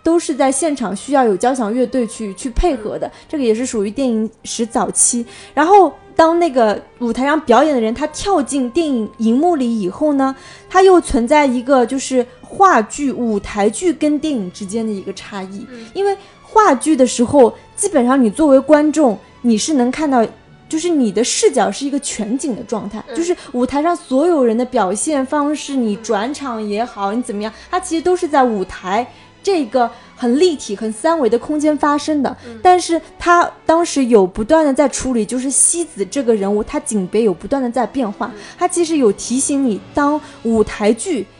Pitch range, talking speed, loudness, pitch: 230-305 Hz, 280 characters per minute, -16 LUFS, 260 Hz